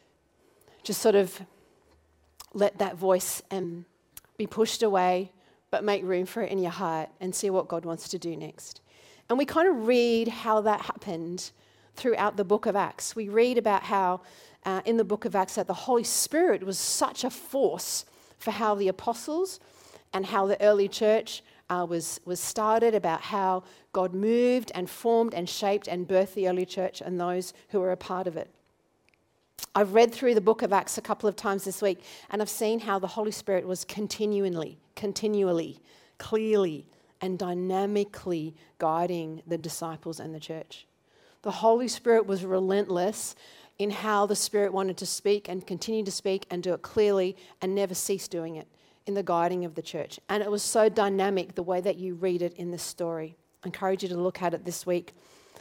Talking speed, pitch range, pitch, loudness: 190 wpm, 180-215 Hz, 195 Hz, -28 LUFS